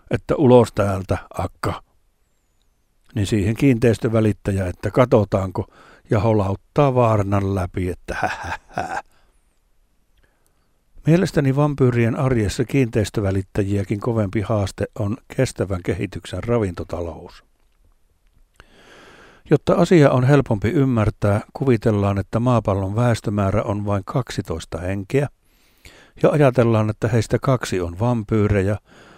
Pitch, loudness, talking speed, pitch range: 110 Hz, -20 LUFS, 95 wpm, 100-125 Hz